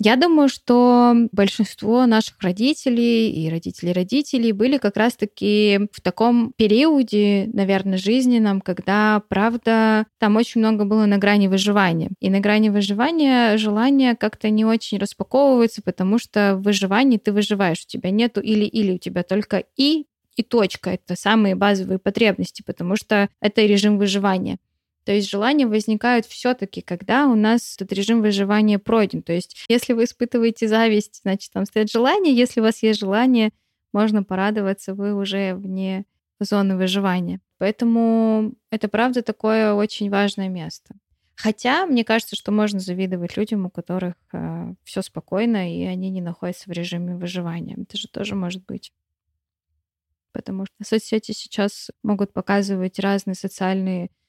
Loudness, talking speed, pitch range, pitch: -20 LUFS, 145 wpm, 190-225 Hz, 210 Hz